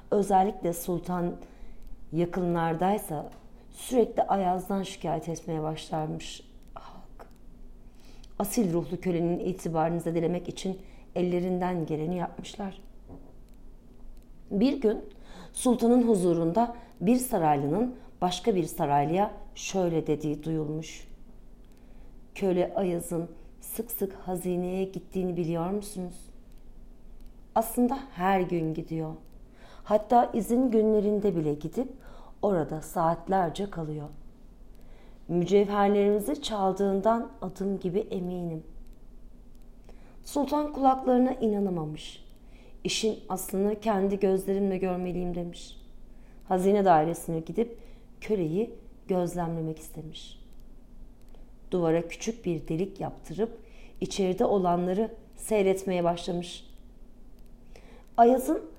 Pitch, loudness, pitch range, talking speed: 185 Hz, -28 LUFS, 170-215 Hz, 80 wpm